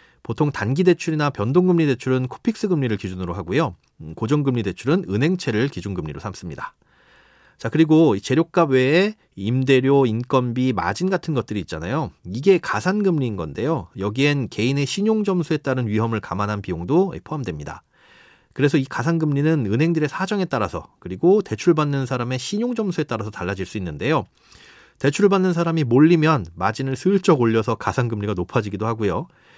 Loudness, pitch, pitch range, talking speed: -21 LUFS, 135 Hz, 110-165 Hz, 380 characters per minute